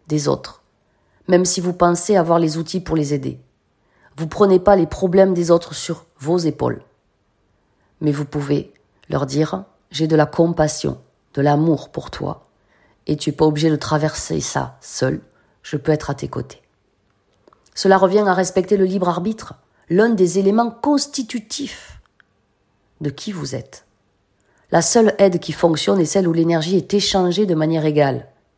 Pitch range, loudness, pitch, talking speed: 145-190 Hz, -18 LUFS, 165 Hz, 165 wpm